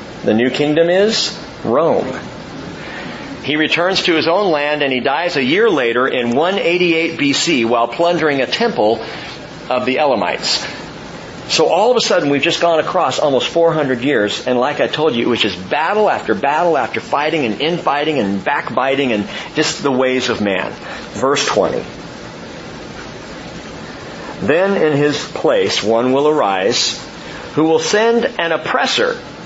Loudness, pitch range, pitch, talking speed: -15 LUFS, 130-170 Hz, 150 Hz, 155 wpm